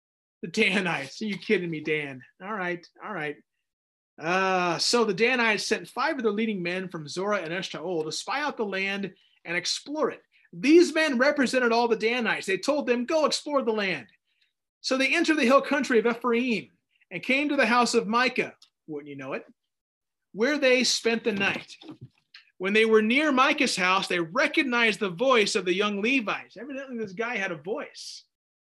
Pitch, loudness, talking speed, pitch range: 220 Hz, -25 LUFS, 190 wpm, 185-255 Hz